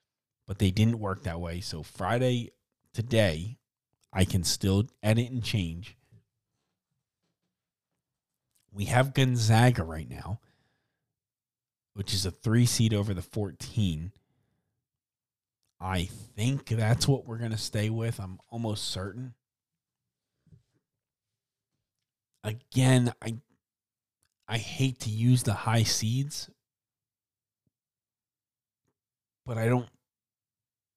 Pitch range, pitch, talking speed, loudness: 105-125 Hz, 115 Hz, 100 wpm, -29 LUFS